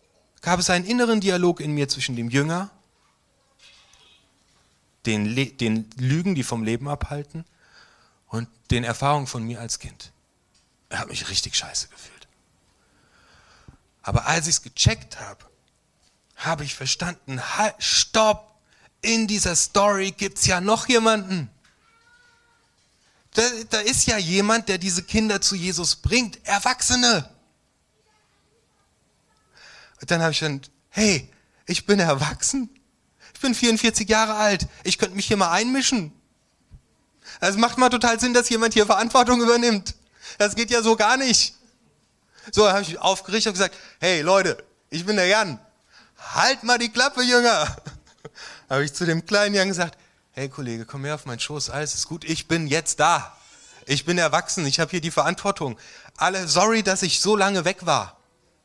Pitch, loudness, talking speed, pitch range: 190 Hz, -21 LUFS, 155 wpm, 150-220 Hz